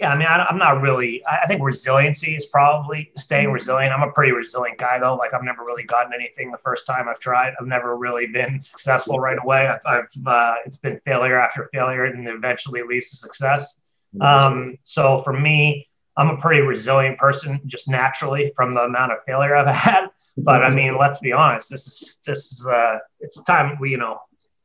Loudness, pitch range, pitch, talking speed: -19 LUFS, 125-140 Hz, 135 Hz, 205 wpm